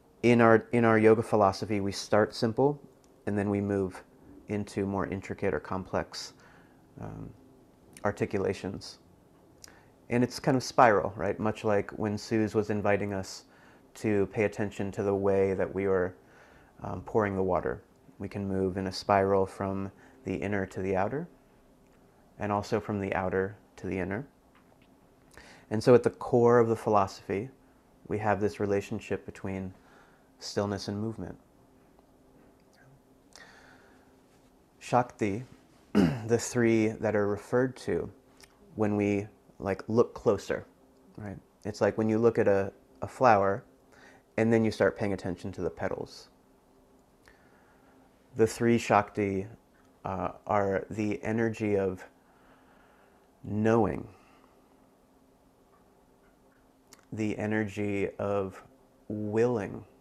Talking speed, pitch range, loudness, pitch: 125 wpm, 95-110 Hz, -29 LUFS, 100 Hz